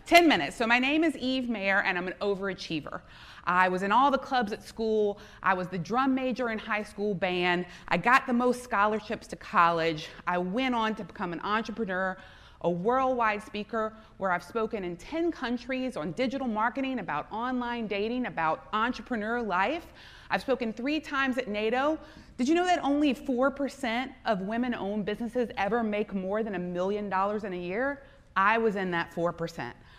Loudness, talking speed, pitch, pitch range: -29 LUFS, 185 wpm, 220 Hz, 190-255 Hz